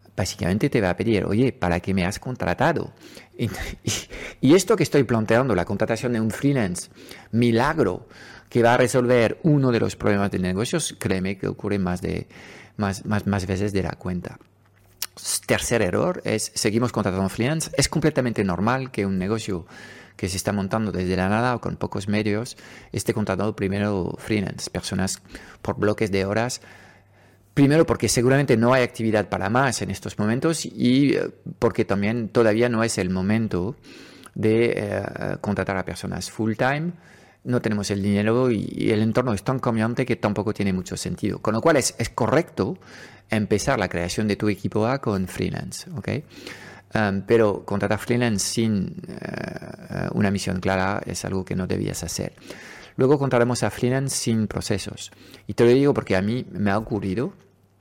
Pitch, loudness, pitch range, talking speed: 110 Hz, -23 LUFS, 100-120 Hz, 175 wpm